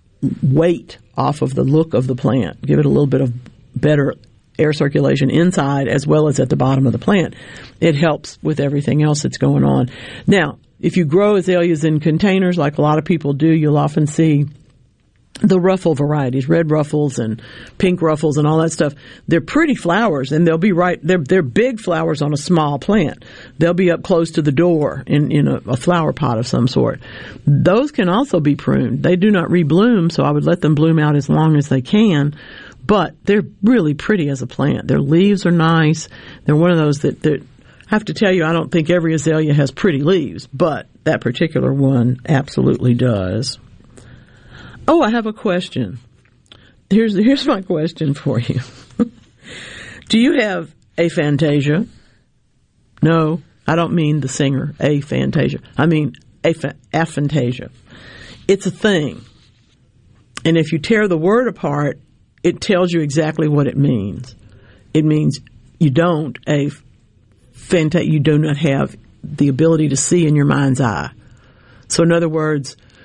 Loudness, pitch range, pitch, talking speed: -16 LUFS, 130-170 Hz, 150 Hz, 175 wpm